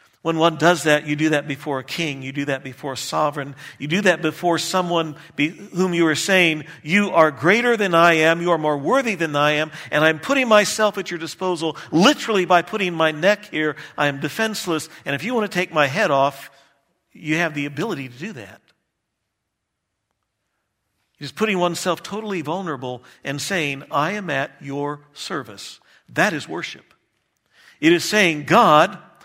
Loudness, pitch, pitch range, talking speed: -20 LUFS, 165 Hz, 145-185 Hz, 185 wpm